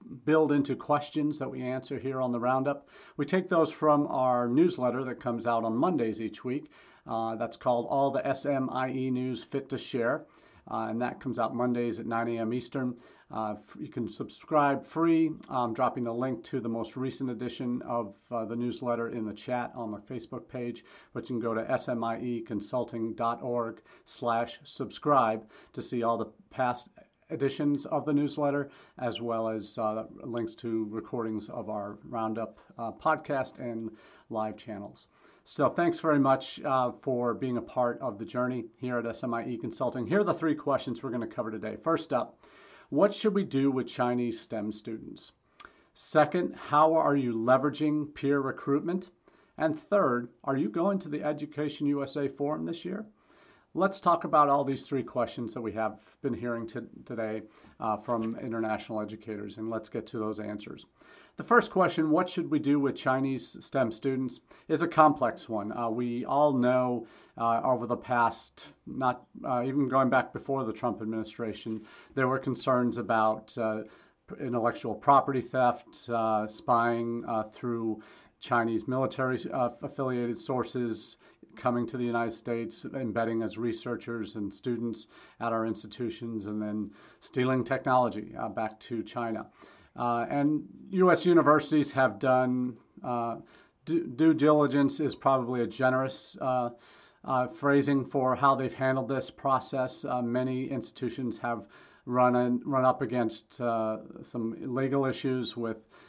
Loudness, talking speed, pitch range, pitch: -30 LUFS, 160 wpm, 115-140 Hz, 125 Hz